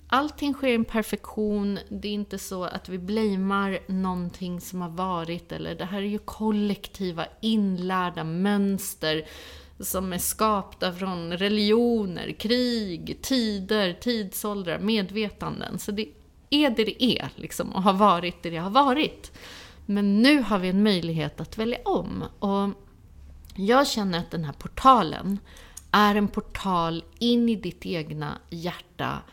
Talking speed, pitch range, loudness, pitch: 145 wpm, 175-215 Hz, -26 LUFS, 200 Hz